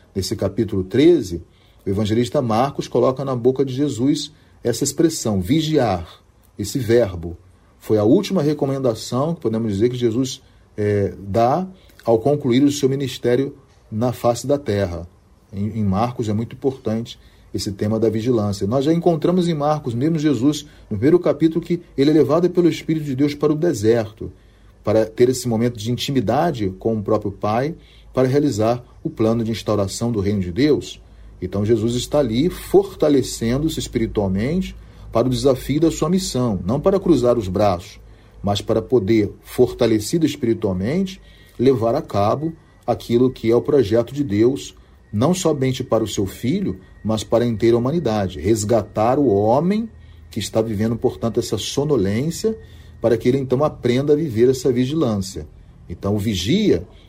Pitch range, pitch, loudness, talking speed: 105-140 Hz, 115 Hz, -19 LUFS, 160 wpm